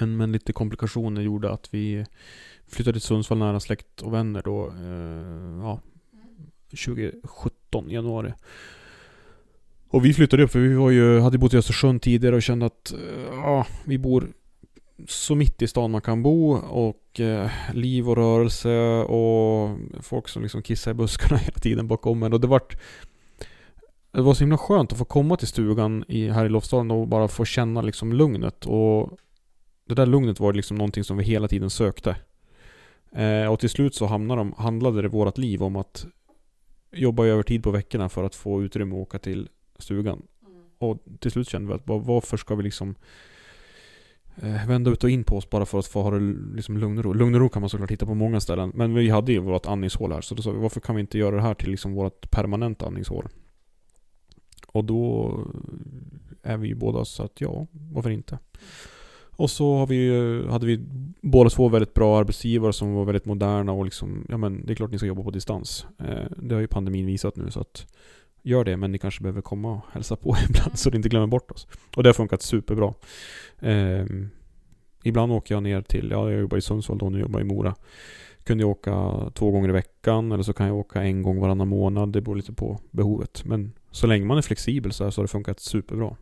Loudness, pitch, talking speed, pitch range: -24 LUFS, 110 Hz, 210 wpm, 100-120 Hz